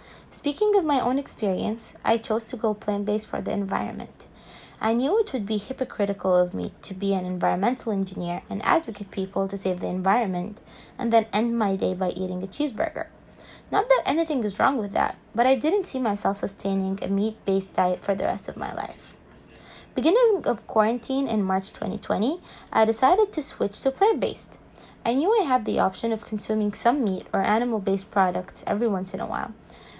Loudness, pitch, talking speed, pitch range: -25 LUFS, 215 Hz, 195 wpm, 195-250 Hz